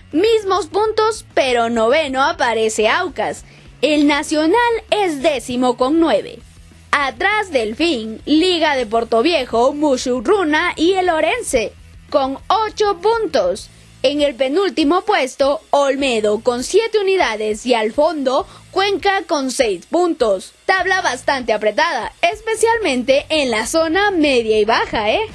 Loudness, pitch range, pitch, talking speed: -16 LUFS, 255-375 Hz, 305 Hz, 125 wpm